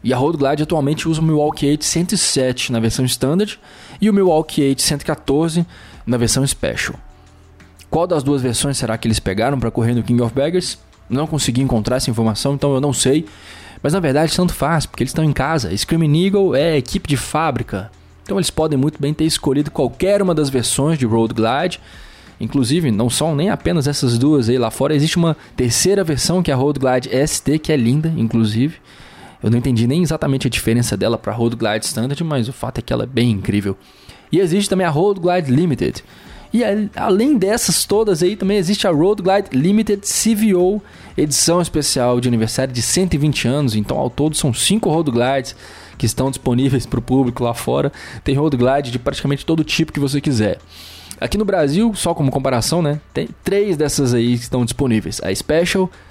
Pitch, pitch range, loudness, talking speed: 140 Hz, 120-165 Hz, -17 LUFS, 200 wpm